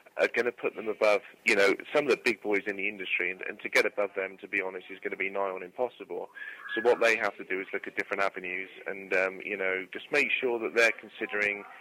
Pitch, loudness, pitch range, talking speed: 100 Hz, -29 LUFS, 95-110 Hz, 270 wpm